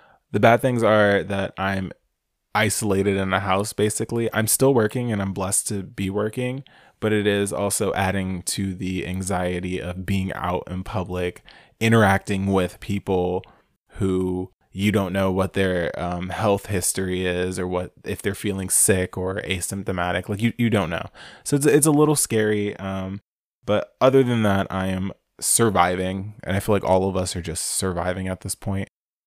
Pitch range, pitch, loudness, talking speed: 95-105 Hz, 95 Hz, -22 LUFS, 175 wpm